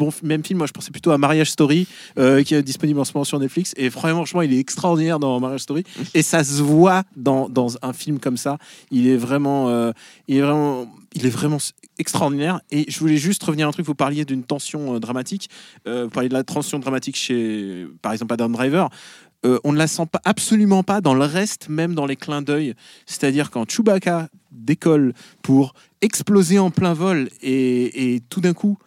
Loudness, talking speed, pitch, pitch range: -20 LUFS, 215 wpm, 150 Hz, 130-170 Hz